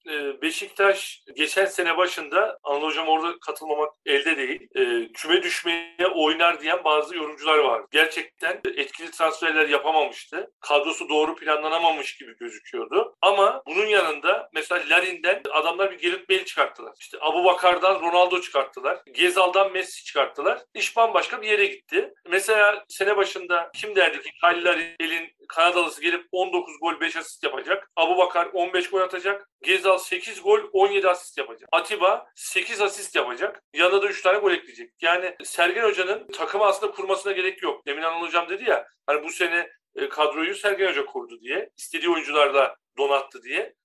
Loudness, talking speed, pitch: -23 LUFS, 150 wpm, 185 Hz